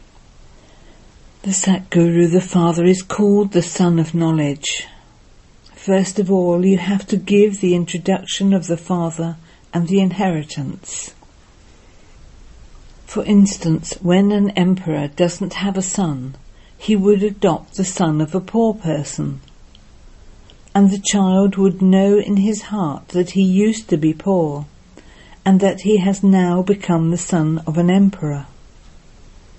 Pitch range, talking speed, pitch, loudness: 165-195 Hz, 140 wpm, 185 Hz, -17 LUFS